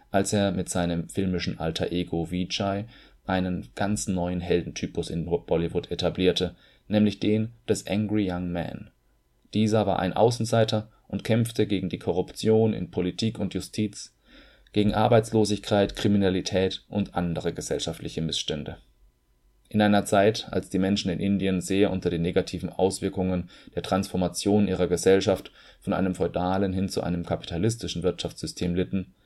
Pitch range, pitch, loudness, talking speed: 90-105 Hz, 95 Hz, -26 LUFS, 135 wpm